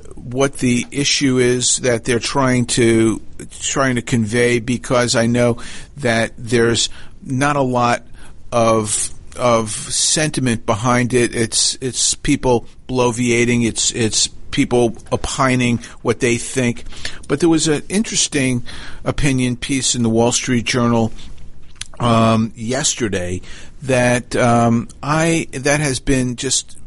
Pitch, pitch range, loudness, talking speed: 120 Hz, 115-130 Hz, -17 LUFS, 125 wpm